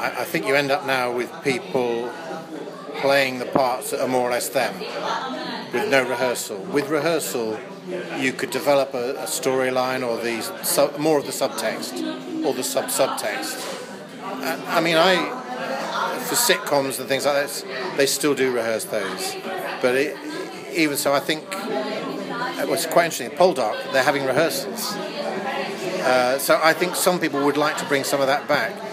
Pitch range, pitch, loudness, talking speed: 130-160 Hz, 140 Hz, -22 LUFS, 170 wpm